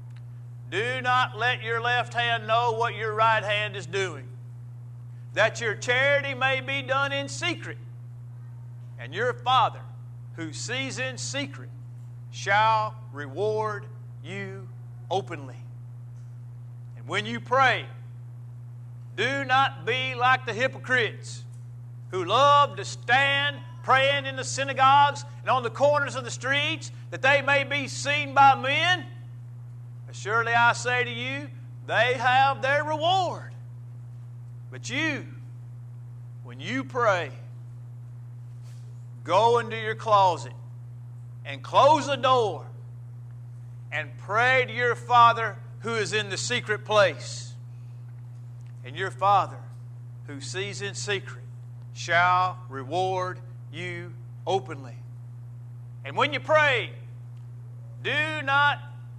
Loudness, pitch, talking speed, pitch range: -24 LUFS, 120 Hz, 115 wpm, 120-130 Hz